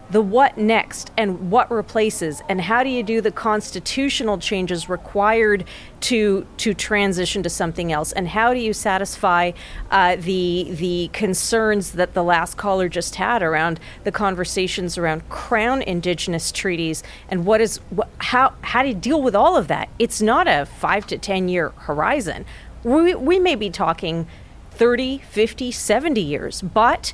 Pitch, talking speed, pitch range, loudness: 200 Hz, 165 wpm, 180-225 Hz, -20 LUFS